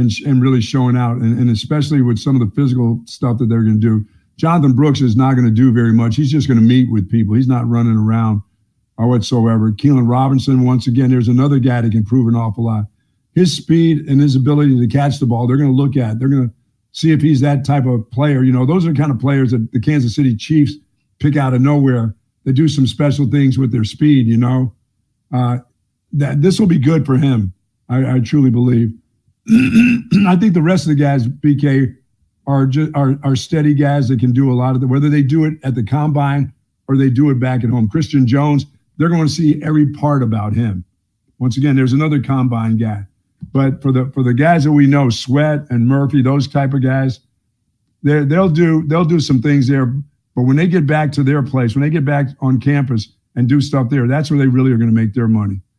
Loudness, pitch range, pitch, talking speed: -14 LUFS, 120-145 Hz, 130 Hz, 235 wpm